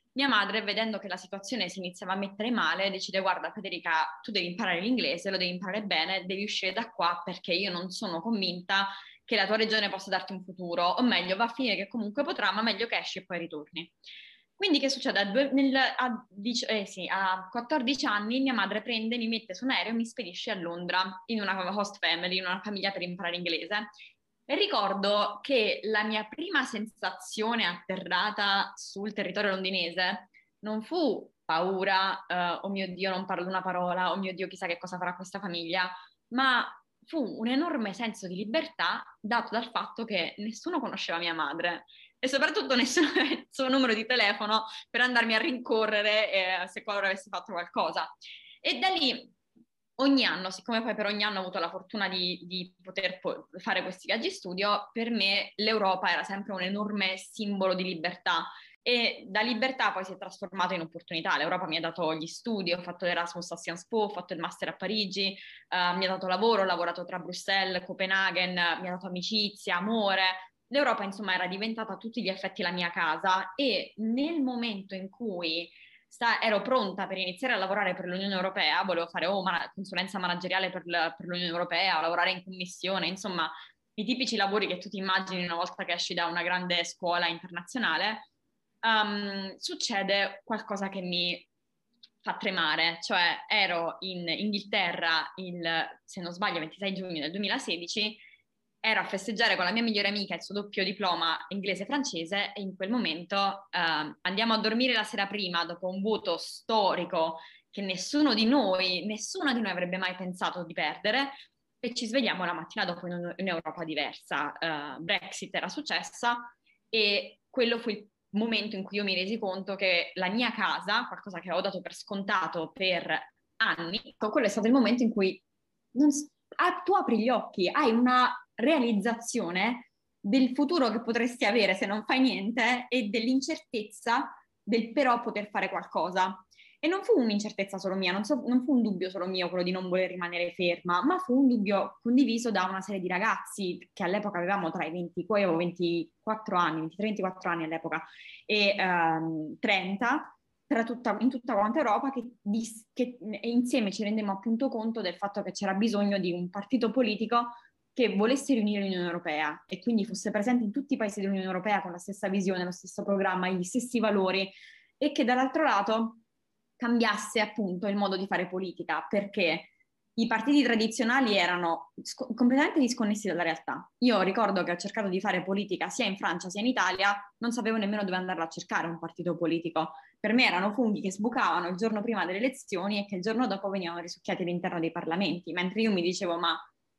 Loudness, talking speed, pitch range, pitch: -29 LUFS, 185 wpm, 180-230 Hz, 200 Hz